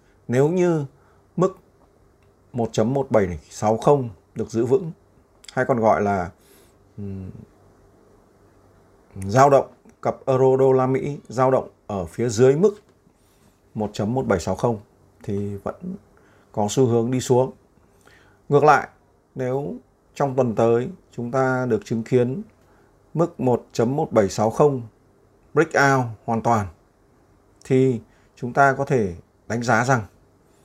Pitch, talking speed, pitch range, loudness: 115 Hz, 115 wpm, 100-130 Hz, -21 LUFS